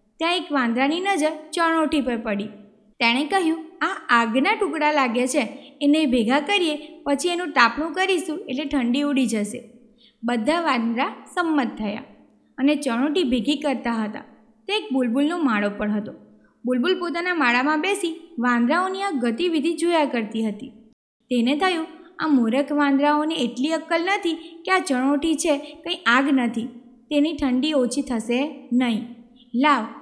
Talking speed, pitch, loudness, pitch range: 140 wpm, 280 Hz, -22 LUFS, 240-320 Hz